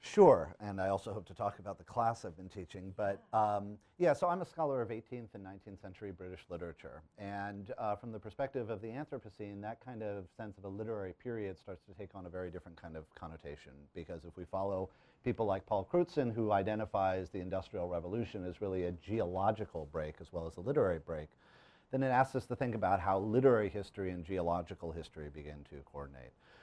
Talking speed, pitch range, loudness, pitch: 210 wpm, 90-110 Hz, -37 LUFS, 100 Hz